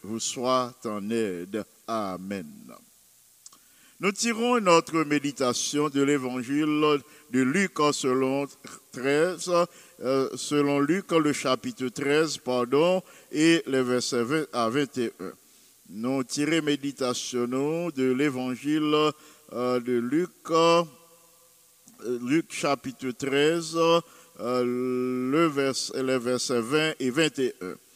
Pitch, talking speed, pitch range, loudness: 140 Hz, 105 wpm, 125-165 Hz, -26 LUFS